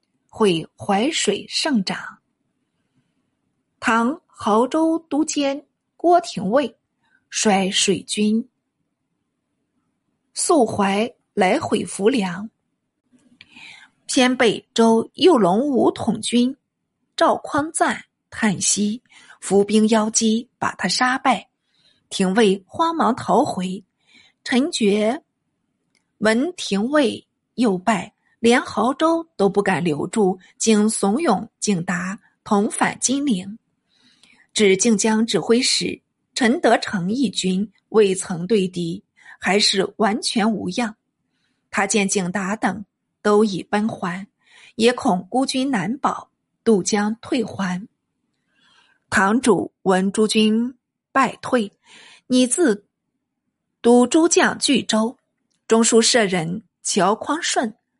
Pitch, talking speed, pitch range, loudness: 220 Hz, 140 characters per minute, 200-255 Hz, -19 LUFS